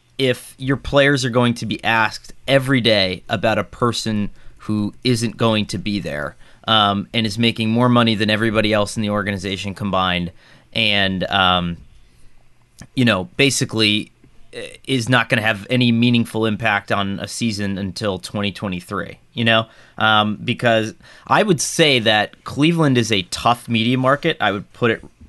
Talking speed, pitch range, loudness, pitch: 160 wpm, 100-120 Hz, -18 LUFS, 110 Hz